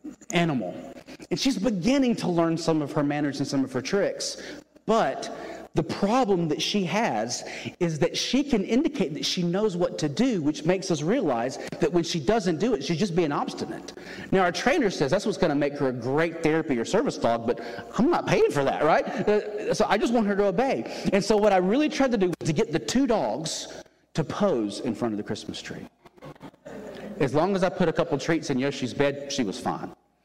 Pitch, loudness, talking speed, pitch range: 185 Hz, -25 LUFS, 220 wpm, 160-220 Hz